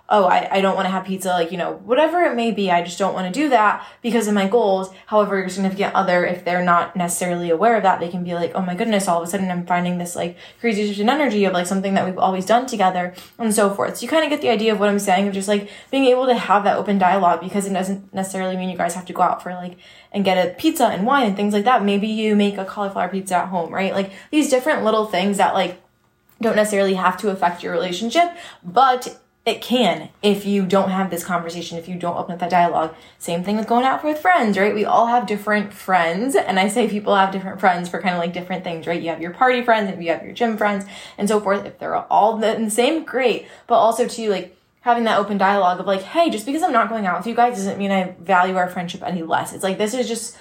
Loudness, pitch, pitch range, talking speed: -19 LUFS, 195 Hz, 180-225 Hz, 270 wpm